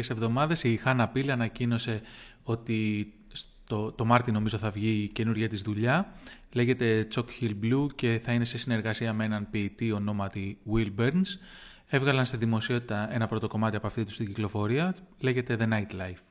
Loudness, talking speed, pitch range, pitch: -29 LUFS, 170 wpm, 110-125 Hz, 115 Hz